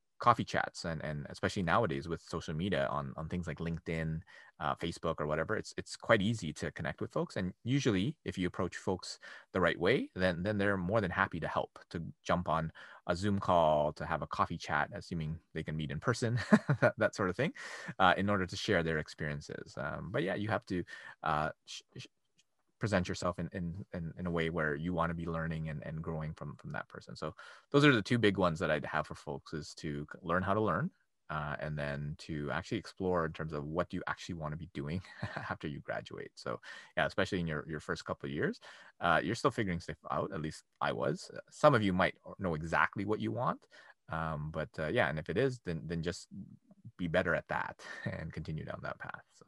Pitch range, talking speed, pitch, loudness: 80-95 Hz, 230 wpm, 85 Hz, -35 LUFS